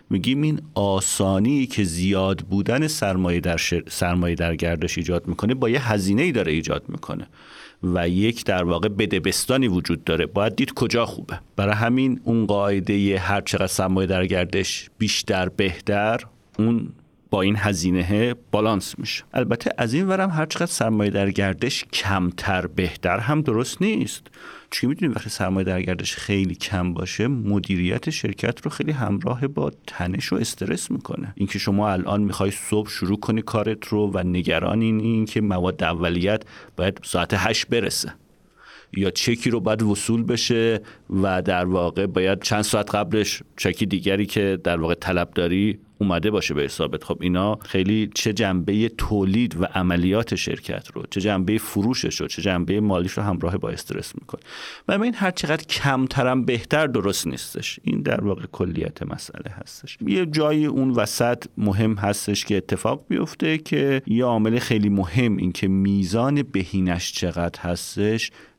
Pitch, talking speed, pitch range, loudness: 100 Hz, 155 wpm, 95-115 Hz, -22 LUFS